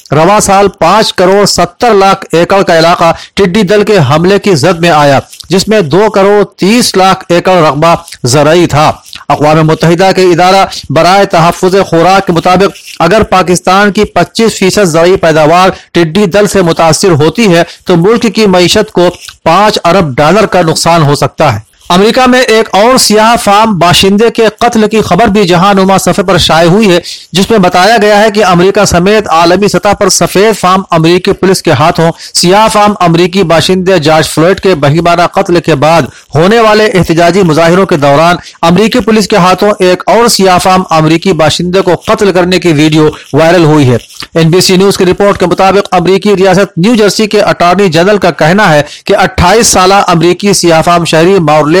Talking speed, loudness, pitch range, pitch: 175 wpm, -5 LUFS, 170-200 Hz, 185 Hz